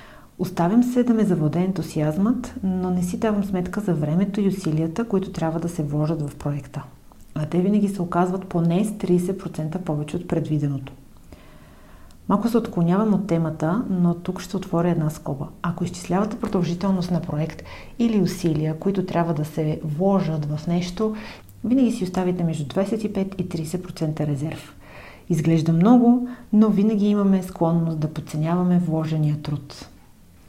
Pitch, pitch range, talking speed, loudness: 175 Hz, 155-195 Hz, 150 wpm, -23 LUFS